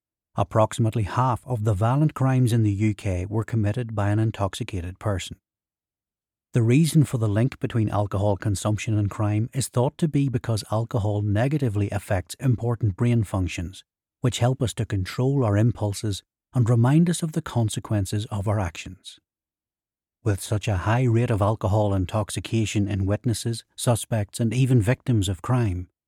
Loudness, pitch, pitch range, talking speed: -24 LUFS, 110 Hz, 105-125 Hz, 155 wpm